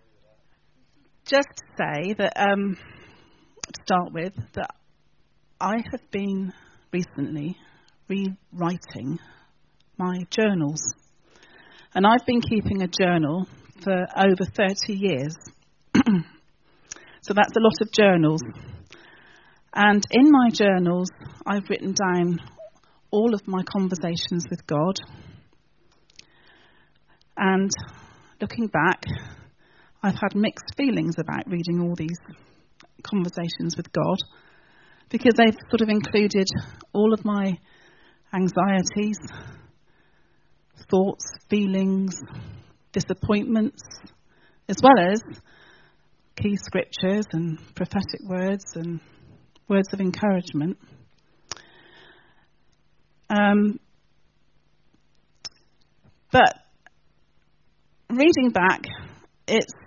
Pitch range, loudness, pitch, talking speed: 175-210 Hz, -23 LUFS, 190 Hz, 90 wpm